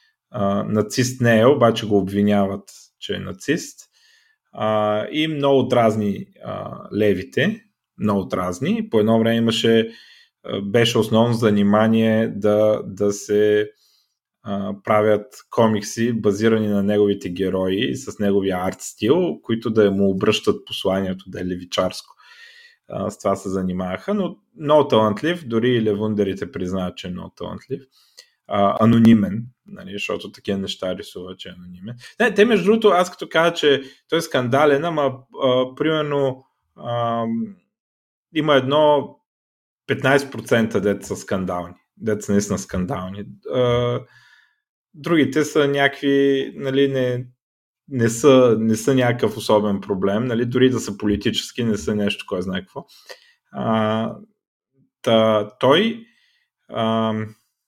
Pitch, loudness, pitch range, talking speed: 115 Hz, -20 LUFS, 100-140 Hz, 125 wpm